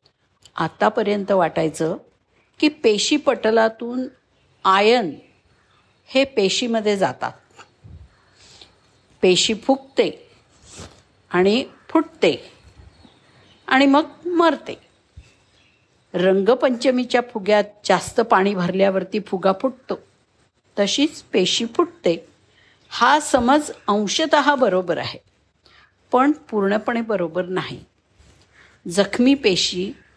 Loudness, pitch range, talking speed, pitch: -19 LUFS, 180-270 Hz, 80 wpm, 210 Hz